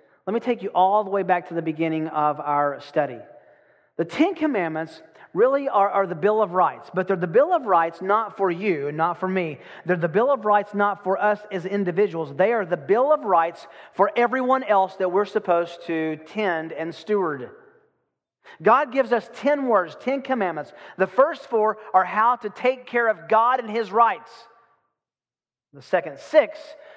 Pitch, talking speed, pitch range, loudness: 205 Hz, 190 wpm, 175-240 Hz, -22 LUFS